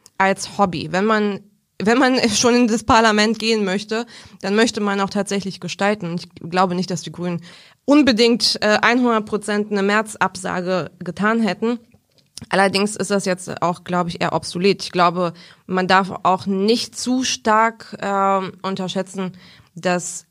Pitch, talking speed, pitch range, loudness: 195 Hz, 155 wpm, 180-220 Hz, -19 LUFS